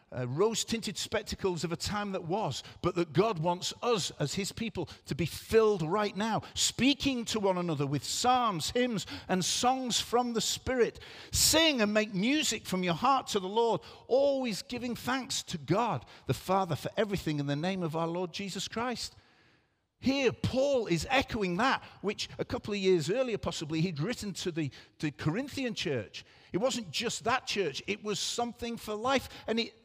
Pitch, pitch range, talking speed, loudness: 205 Hz, 175-240 Hz, 190 wpm, -31 LUFS